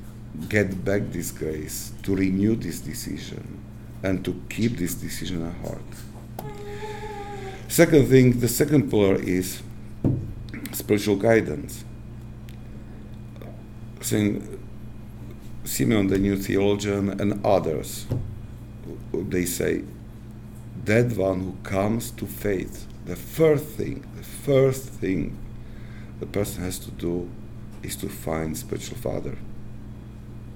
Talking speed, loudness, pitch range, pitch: 105 wpm, -25 LUFS, 100-115 Hz, 110 Hz